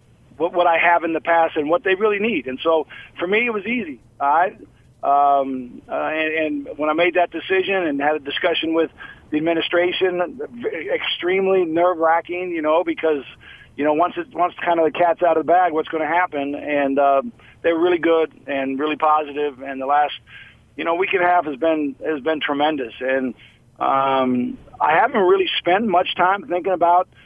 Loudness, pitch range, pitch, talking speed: -19 LUFS, 145-180 Hz, 165 Hz, 205 wpm